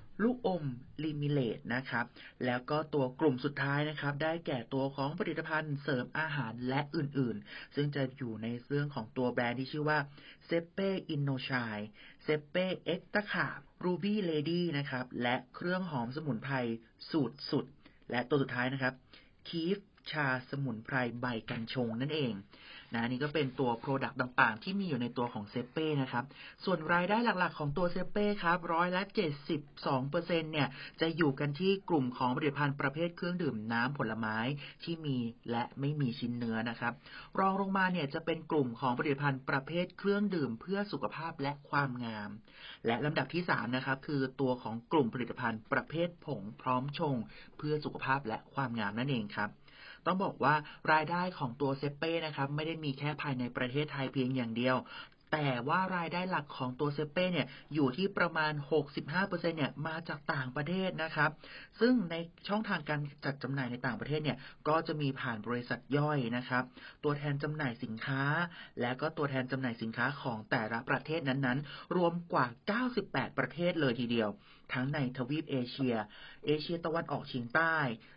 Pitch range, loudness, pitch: 125-160 Hz, -35 LUFS, 145 Hz